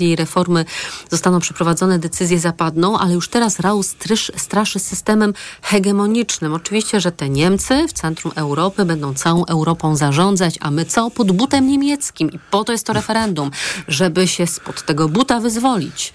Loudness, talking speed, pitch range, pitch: -17 LUFS, 155 wpm, 165-215 Hz, 185 Hz